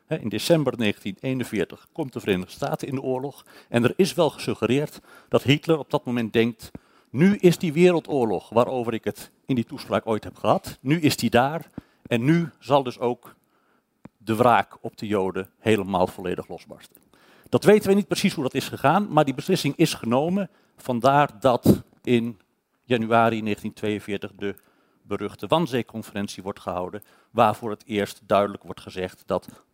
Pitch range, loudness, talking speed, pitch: 105-145 Hz, -24 LUFS, 165 wpm, 120 Hz